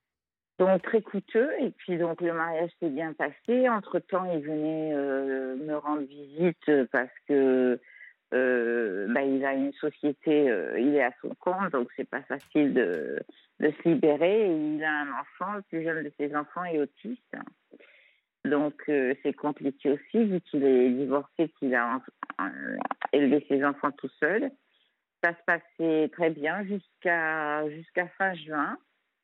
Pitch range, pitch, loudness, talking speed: 140-180 Hz, 150 Hz, -28 LUFS, 165 wpm